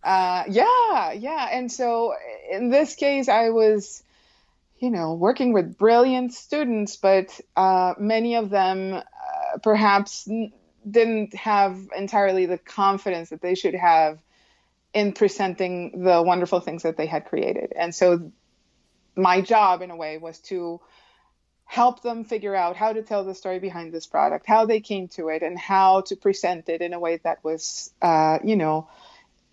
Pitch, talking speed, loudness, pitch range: 195 Hz, 165 wpm, -22 LUFS, 175-225 Hz